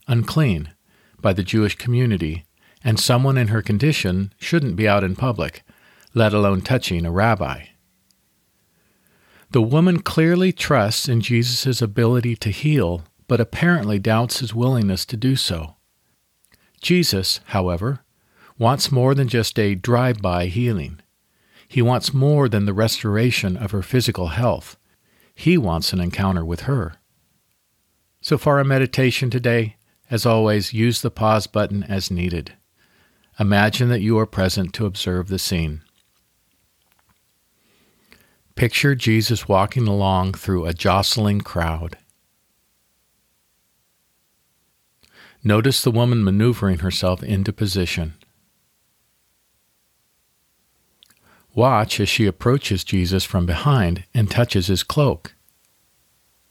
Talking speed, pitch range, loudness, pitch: 120 wpm, 95-120 Hz, -19 LUFS, 105 Hz